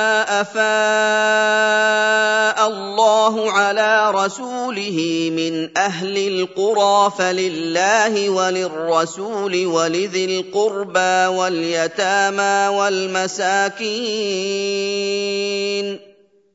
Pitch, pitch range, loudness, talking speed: 200 Hz, 185-215 Hz, -18 LUFS, 45 wpm